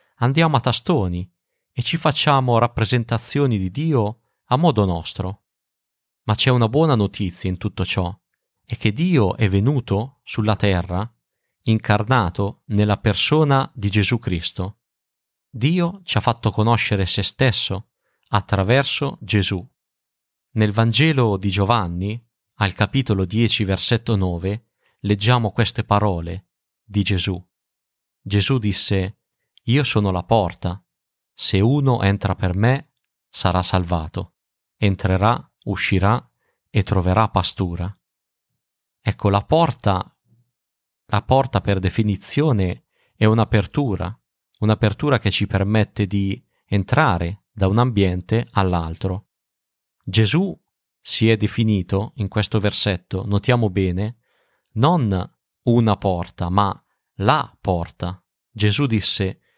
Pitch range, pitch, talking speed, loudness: 95-120 Hz, 105 Hz, 110 wpm, -20 LUFS